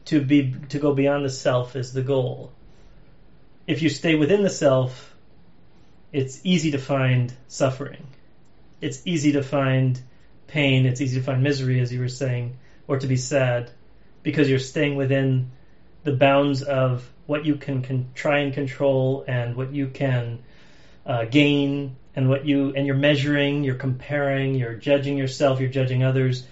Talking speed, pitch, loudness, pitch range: 165 wpm, 135 Hz, -23 LUFS, 130-145 Hz